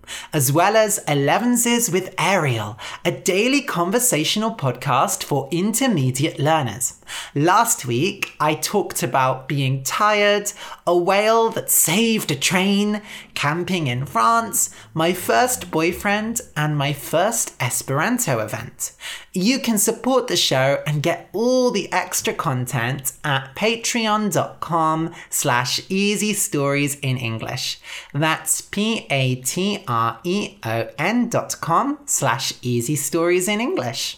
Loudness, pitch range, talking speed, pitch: -20 LUFS, 140-210 Hz, 110 wpm, 170 Hz